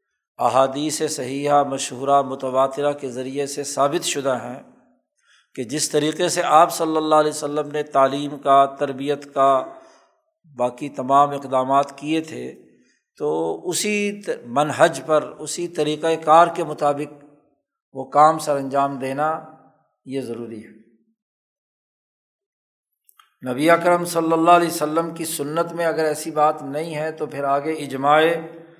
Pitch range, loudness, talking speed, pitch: 140-165 Hz, -20 LUFS, 140 wpm, 150 Hz